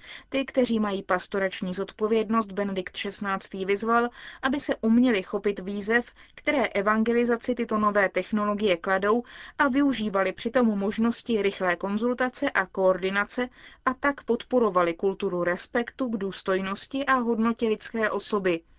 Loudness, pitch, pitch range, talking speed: -26 LUFS, 215 Hz, 195-240 Hz, 125 wpm